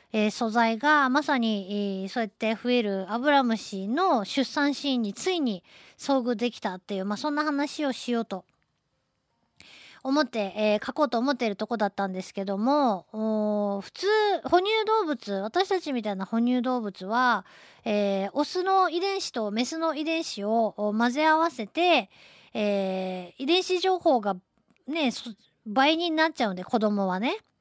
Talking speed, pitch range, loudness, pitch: 285 characters per minute, 210-300 Hz, -26 LUFS, 240 Hz